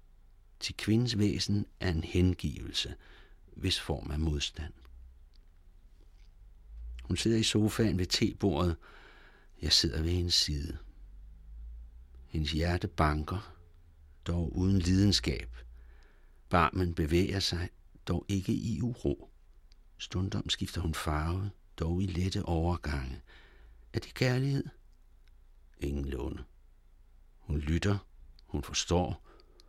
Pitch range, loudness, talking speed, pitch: 75-95 Hz, -32 LUFS, 105 wpm, 85 Hz